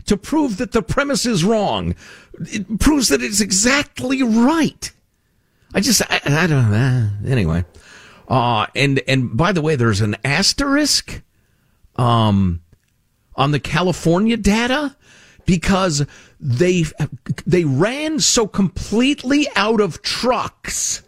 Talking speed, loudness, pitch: 120 wpm, -17 LUFS, 170 Hz